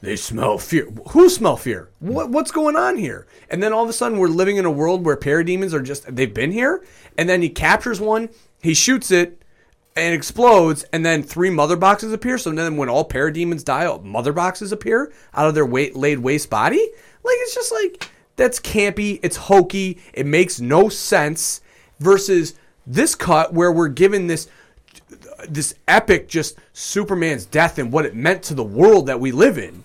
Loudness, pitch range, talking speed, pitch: -18 LUFS, 155-215 Hz, 195 wpm, 175 Hz